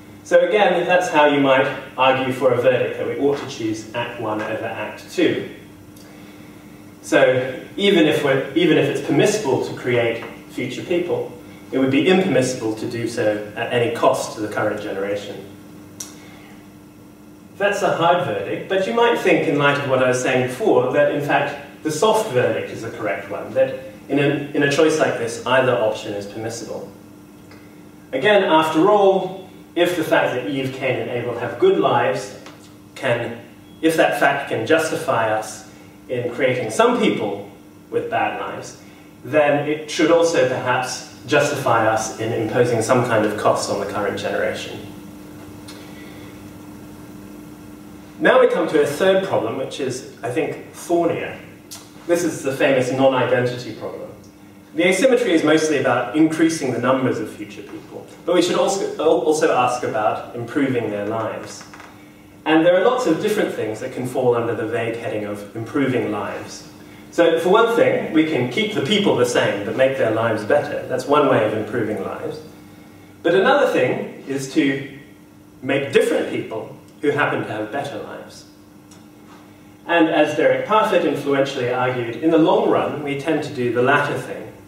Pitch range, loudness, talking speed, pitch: 105-160 Hz, -19 LUFS, 170 wpm, 130 Hz